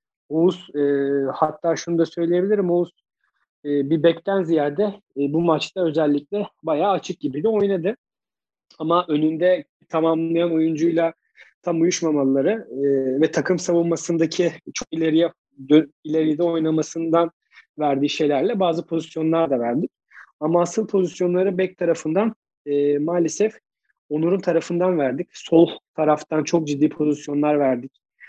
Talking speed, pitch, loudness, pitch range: 115 wpm, 165 Hz, -21 LUFS, 150-175 Hz